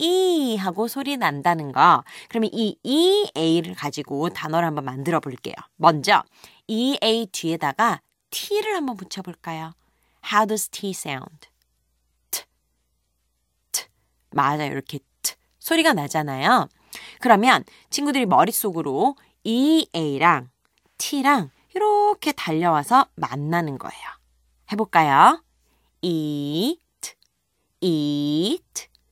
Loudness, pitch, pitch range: -21 LUFS, 170 Hz, 145-235 Hz